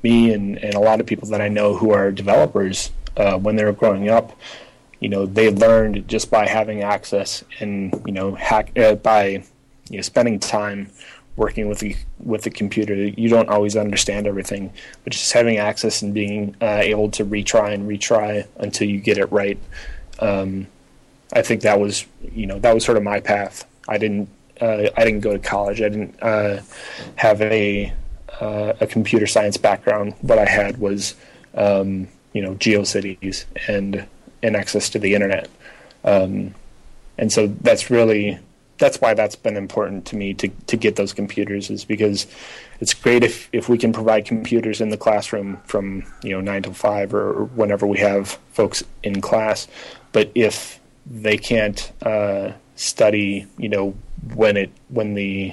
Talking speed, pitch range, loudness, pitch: 185 wpm, 100-110 Hz, -19 LUFS, 105 Hz